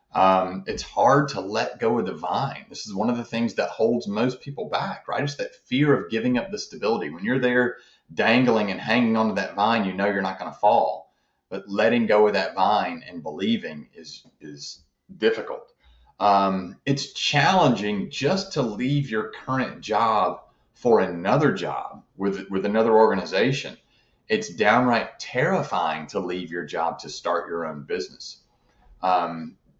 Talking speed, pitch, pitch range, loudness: 170 wpm, 105 Hz, 95-125 Hz, -23 LUFS